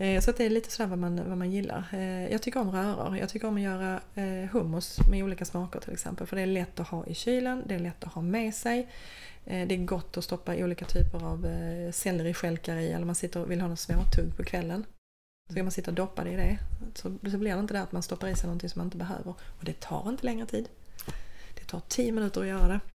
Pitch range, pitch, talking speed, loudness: 175-200 Hz, 185 Hz, 260 wpm, -32 LUFS